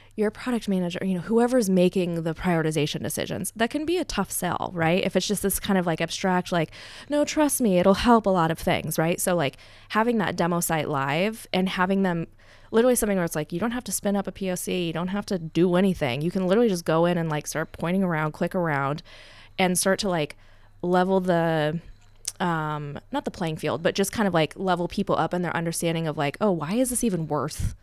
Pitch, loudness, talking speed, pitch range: 180 Hz, -25 LUFS, 235 wpm, 160-195 Hz